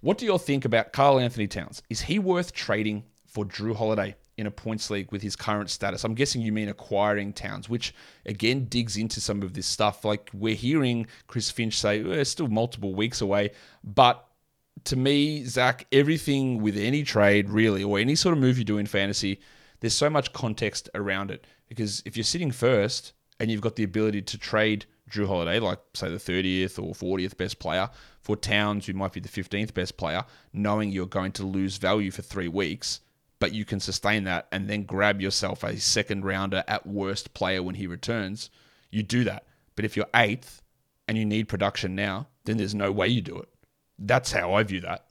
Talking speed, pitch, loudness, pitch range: 210 wpm, 105 Hz, -27 LUFS, 100-115 Hz